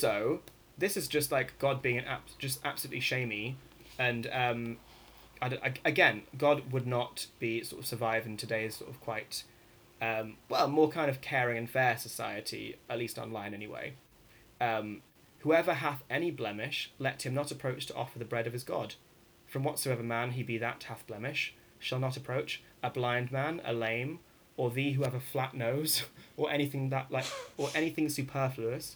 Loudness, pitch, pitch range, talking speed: -34 LUFS, 130 Hz, 115-140 Hz, 180 wpm